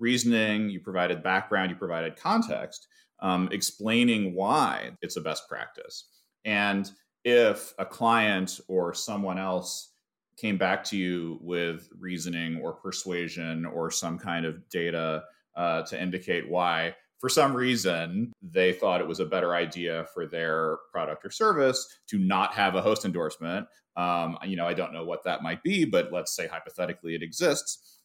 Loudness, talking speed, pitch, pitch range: -28 LUFS, 160 wpm, 95 Hz, 85-115 Hz